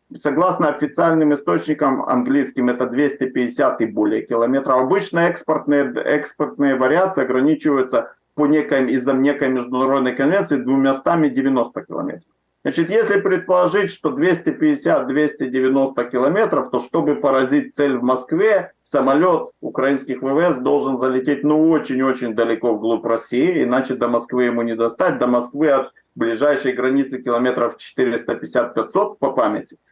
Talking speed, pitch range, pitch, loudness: 120 wpm, 130-150 Hz, 135 Hz, -18 LUFS